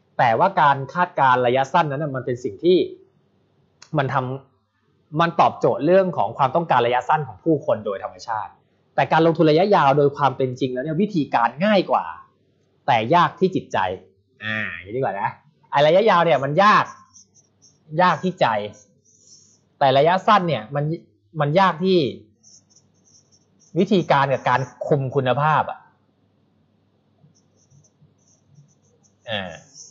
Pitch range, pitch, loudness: 125-175 Hz, 145 Hz, -20 LUFS